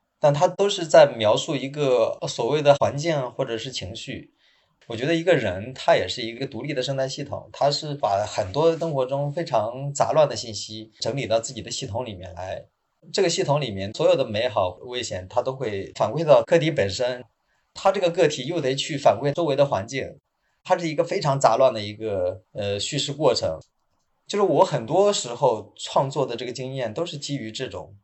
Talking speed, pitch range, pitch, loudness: 295 characters per minute, 115-155 Hz, 135 Hz, -23 LUFS